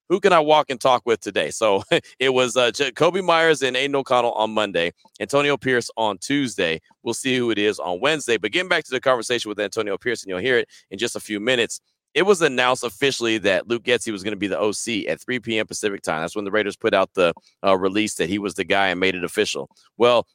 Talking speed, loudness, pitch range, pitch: 250 wpm, -21 LUFS, 105-130 Hz, 115 Hz